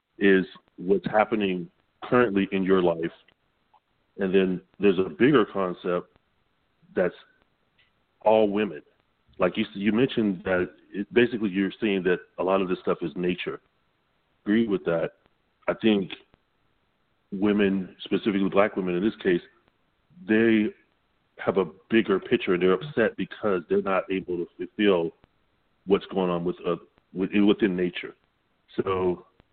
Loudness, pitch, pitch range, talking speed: -25 LUFS, 95 Hz, 90-105 Hz, 140 wpm